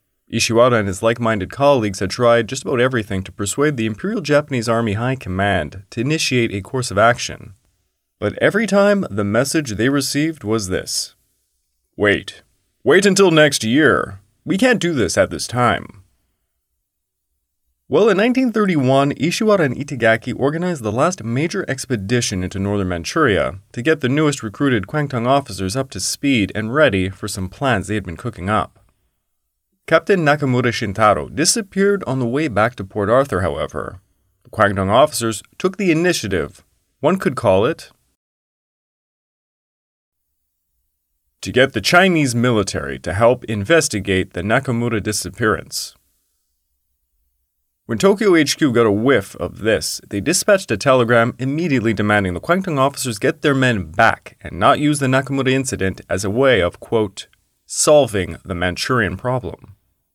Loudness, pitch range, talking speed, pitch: -17 LUFS, 95-140 Hz, 150 wpm, 115 Hz